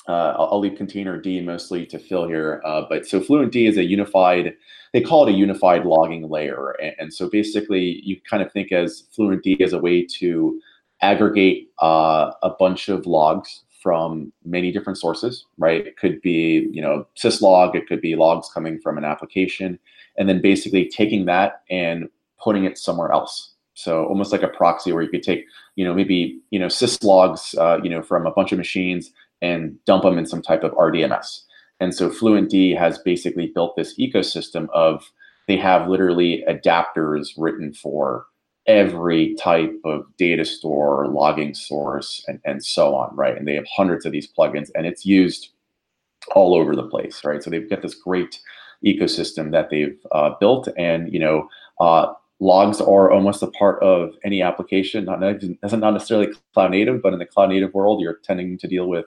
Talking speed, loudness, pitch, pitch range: 185 wpm, -19 LUFS, 90 Hz, 80-95 Hz